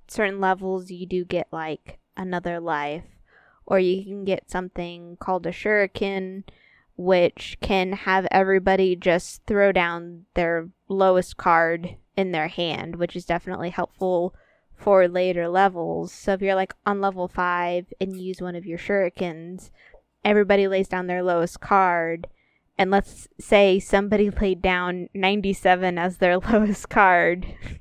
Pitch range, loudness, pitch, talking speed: 175-195 Hz, -23 LUFS, 185 Hz, 145 wpm